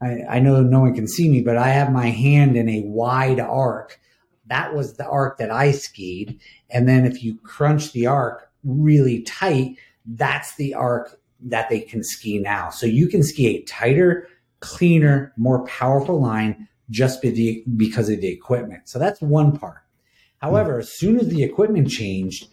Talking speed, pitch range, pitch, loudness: 175 wpm, 115-145 Hz, 130 Hz, -19 LUFS